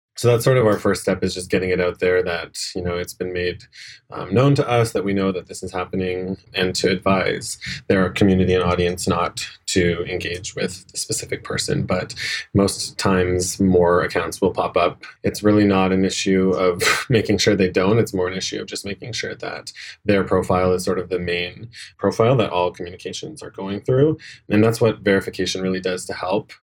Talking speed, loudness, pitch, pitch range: 210 wpm, -20 LUFS, 95 Hz, 90-105 Hz